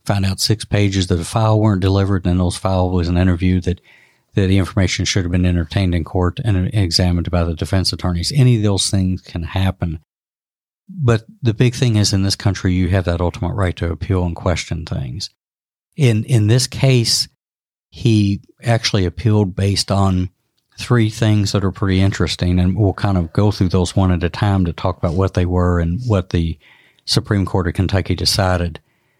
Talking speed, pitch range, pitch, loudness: 195 wpm, 90-105 Hz, 95 Hz, -17 LUFS